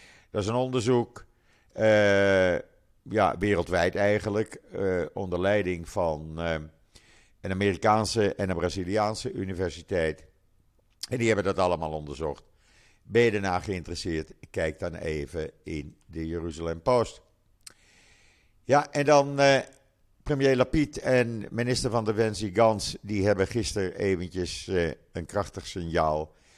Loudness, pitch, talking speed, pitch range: -27 LUFS, 100 Hz, 120 wpm, 90-110 Hz